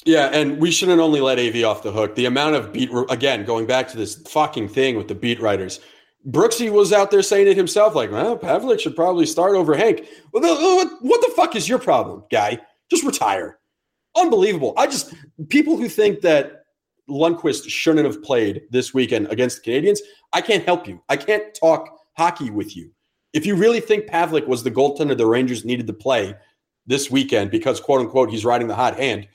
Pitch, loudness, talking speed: 160 Hz, -19 LUFS, 200 wpm